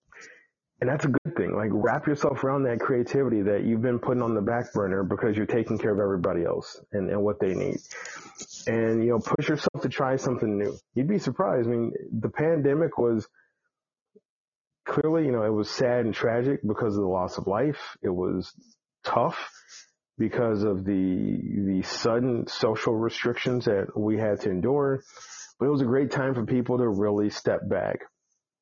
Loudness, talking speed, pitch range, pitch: -26 LUFS, 185 wpm, 105-130 Hz, 115 Hz